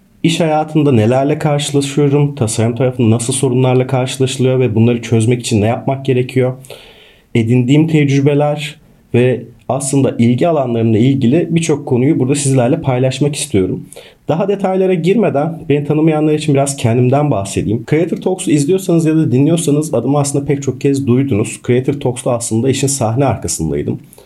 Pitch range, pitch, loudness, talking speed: 125-150 Hz, 135 Hz, -14 LUFS, 140 wpm